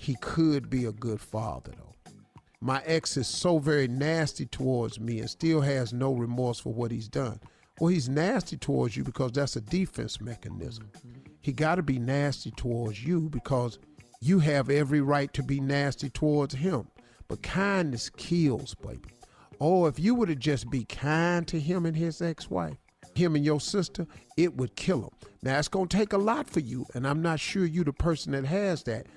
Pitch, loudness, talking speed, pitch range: 145 Hz, -29 LUFS, 195 wpm, 125-165 Hz